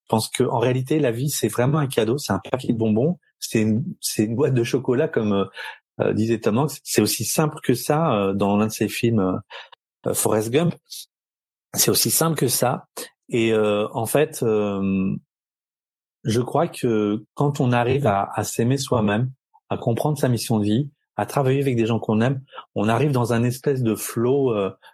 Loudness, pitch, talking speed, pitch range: -22 LUFS, 120 Hz, 200 wpm, 110-145 Hz